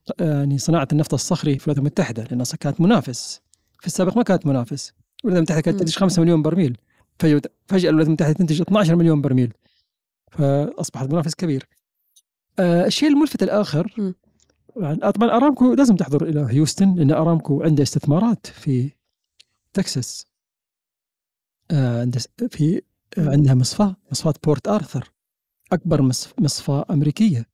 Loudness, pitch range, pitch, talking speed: -19 LUFS, 140-185 Hz, 155 Hz, 125 wpm